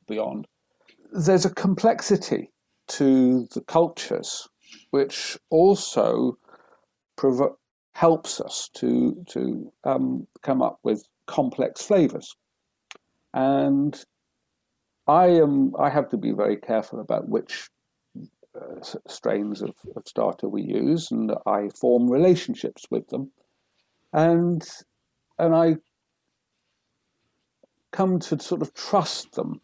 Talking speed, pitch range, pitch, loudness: 105 wpm, 135-190 Hz, 165 Hz, -23 LUFS